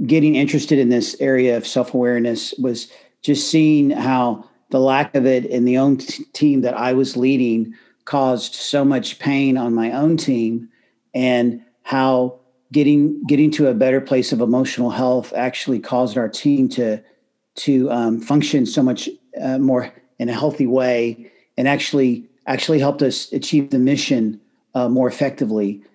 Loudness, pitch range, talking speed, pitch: -18 LUFS, 120-140 Hz, 165 wpm, 130 Hz